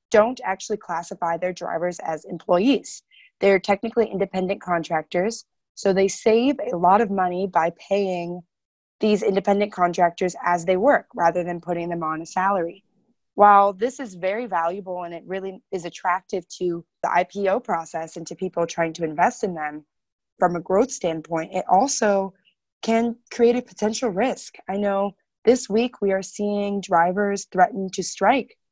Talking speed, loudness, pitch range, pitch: 160 wpm, -22 LUFS, 175-205 Hz, 190 Hz